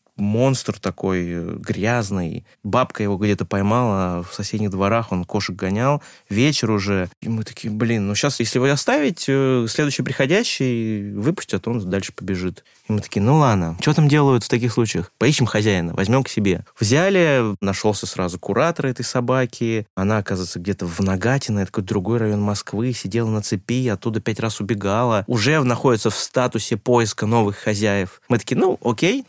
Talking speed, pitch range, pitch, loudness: 165 wpm, 100-125 Hz, 110 Hz, -20 LUFS